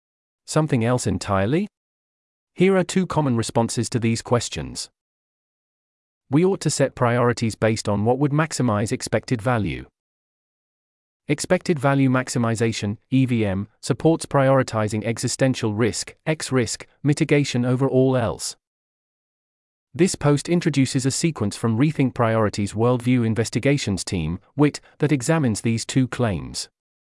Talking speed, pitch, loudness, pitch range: 120 wpm, 125 Hz, -22 LUFS, 115-145 Hz